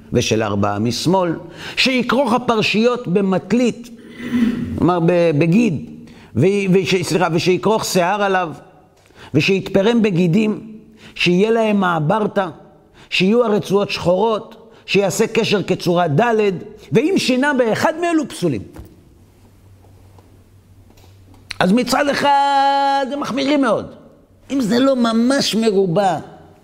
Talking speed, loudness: 95 wpm, -17 LUFS